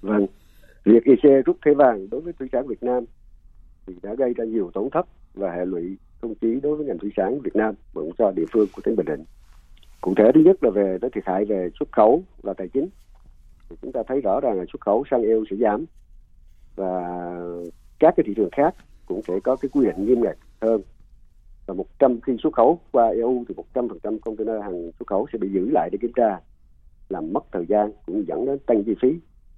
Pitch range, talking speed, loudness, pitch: 90-125 Hz, 225 wpm, -22 LUFS, 105 Hz